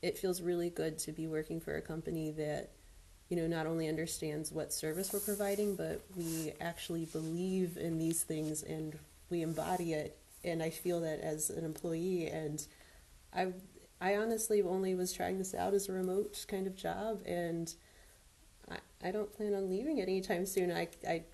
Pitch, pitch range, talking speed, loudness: 165 Hz, 155-190 Hz, 180 wpm, -38 LUFS